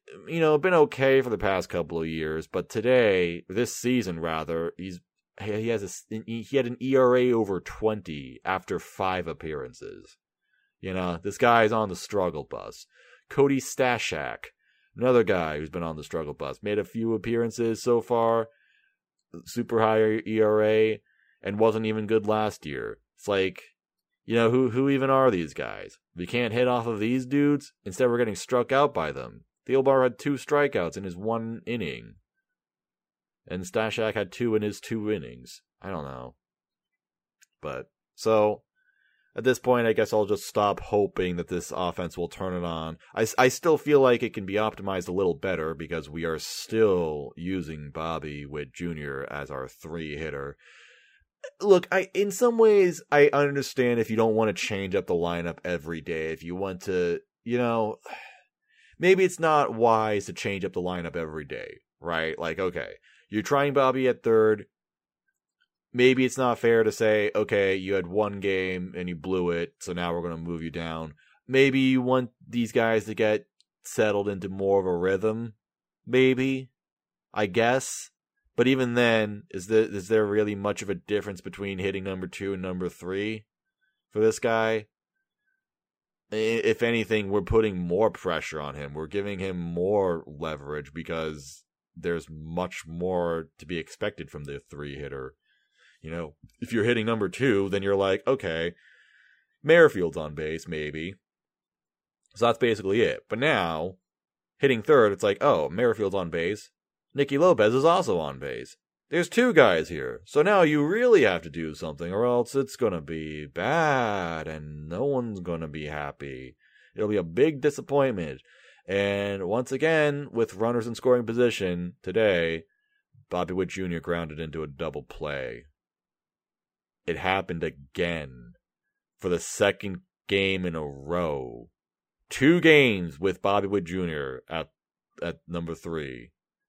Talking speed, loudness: 165 wpm, -26 LUFS